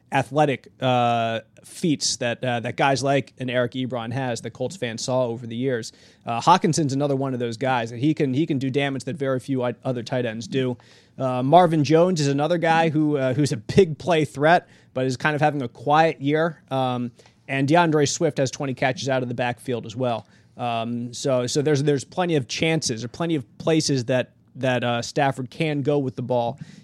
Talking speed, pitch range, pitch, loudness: 210 wpm, 125-150 Hz, 135 Hz, -23 LUFS